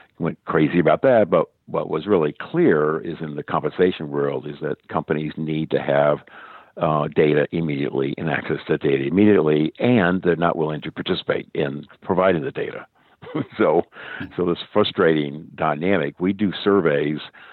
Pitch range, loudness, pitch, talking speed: 75-85 Hz, -21 LUFS, 80 Hz, 155 wpm